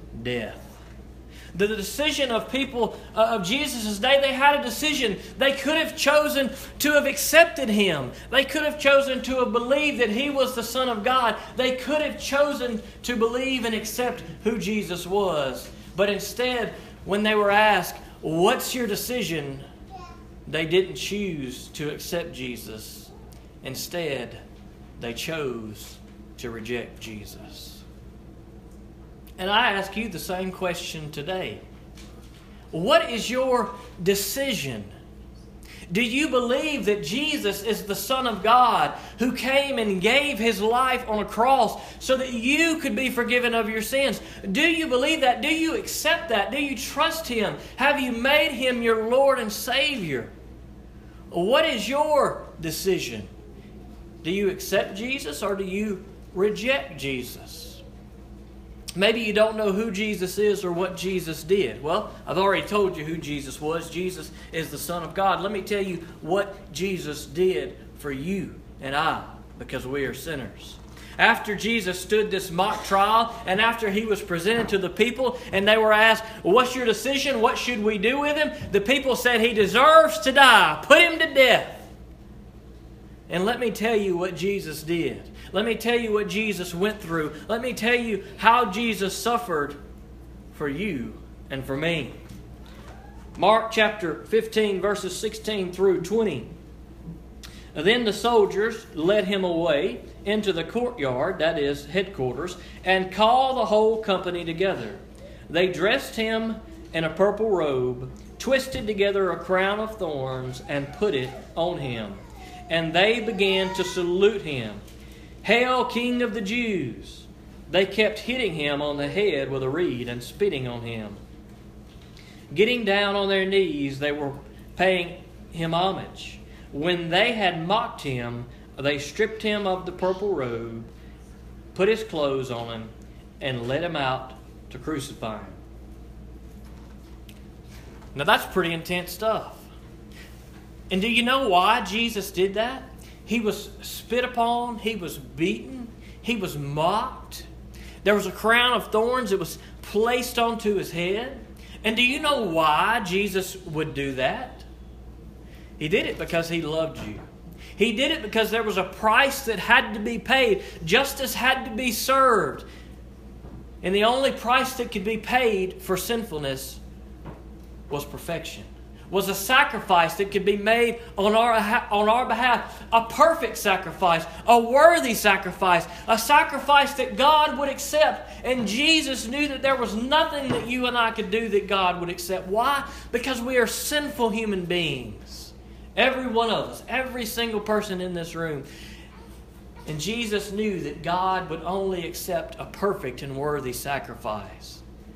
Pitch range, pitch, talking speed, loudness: 160-235 Hz, 200 Hz, 155 wpm, -23 LUFS